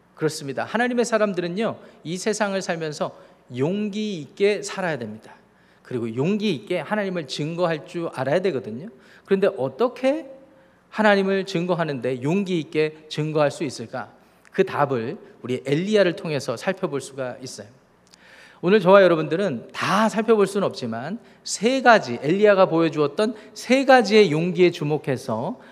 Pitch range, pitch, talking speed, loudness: 150-210 Hz, 185 Hz, 325 characters per minute, -22 LUFS